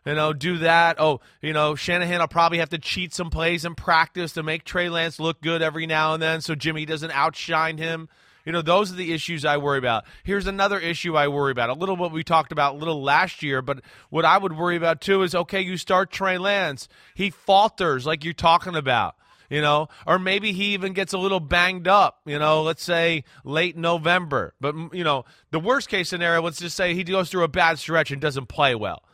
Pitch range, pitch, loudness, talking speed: 155-180 Hz, 165 Hz, -22 LUFS, 235 wpm